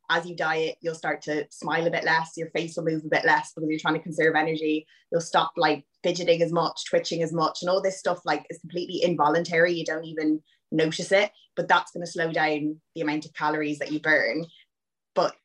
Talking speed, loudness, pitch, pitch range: 225 wpm, -26 LUFS, 165 Hz, 155-170 Hz